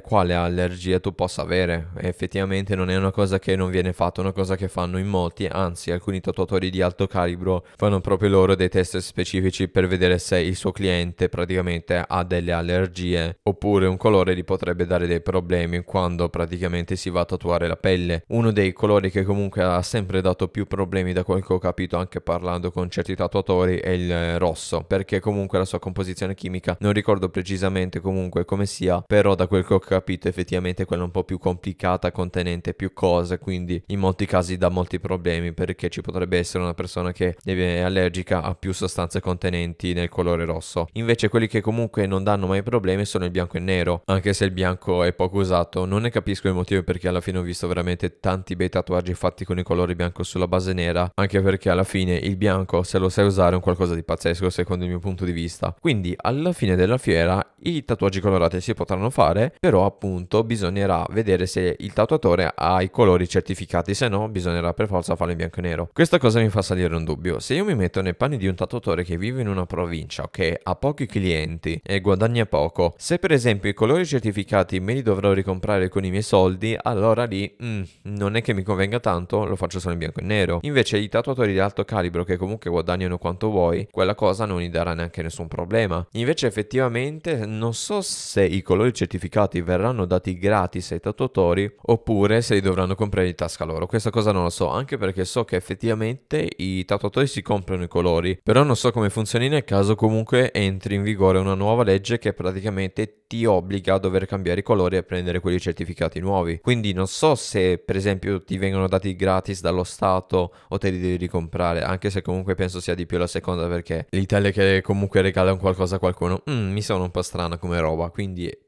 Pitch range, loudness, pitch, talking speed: 90-100 Hz, -23 LUFS, 95 Hz, 210 wpm